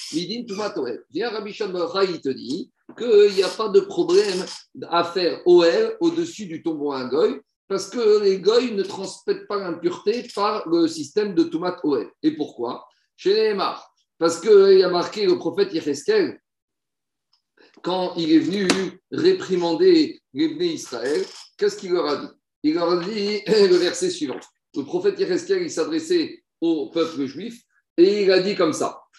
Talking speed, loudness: 165 wpm, -21 LUFS